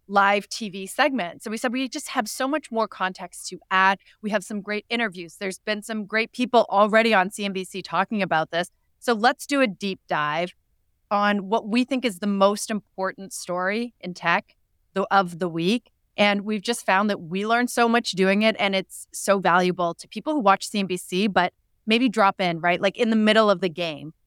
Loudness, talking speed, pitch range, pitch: -23 LUFS, 205 wpm, 185-225 Hz, 200 Hz